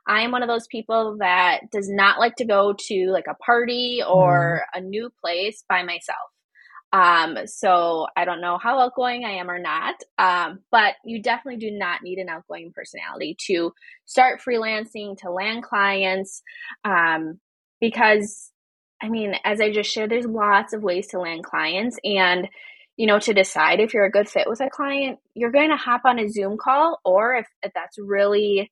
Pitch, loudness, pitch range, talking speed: 210 Hz, -21 LUFS, 185-235 Hz, 190 wpm